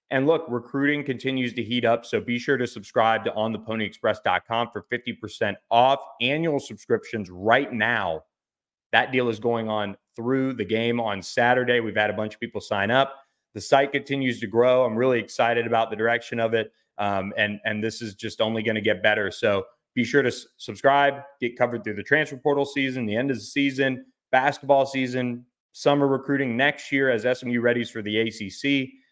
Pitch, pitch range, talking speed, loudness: 120 Hz, 110-135 Hz, 190 wpm, -24 LUFS